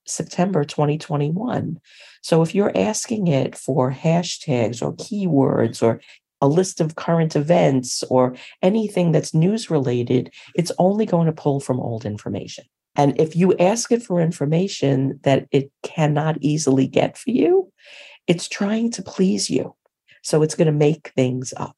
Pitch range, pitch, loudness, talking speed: 135-185 Hz, 160 Hz, -20 LUFS, 155 wpm